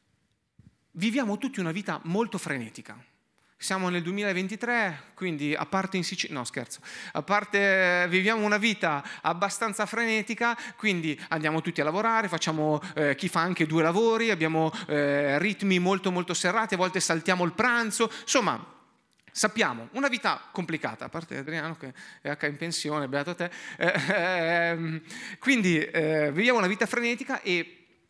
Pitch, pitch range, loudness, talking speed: 180 Hz, 160-215 Hz, -27 LUFS, 150 wpm